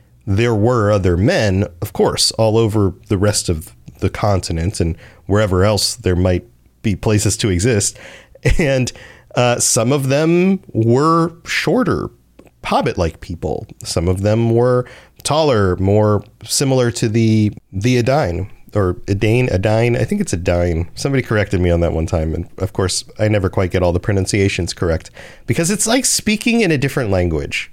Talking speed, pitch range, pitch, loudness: 160 wpm, 95-125 Hz, 105 Hz, -16 LUFS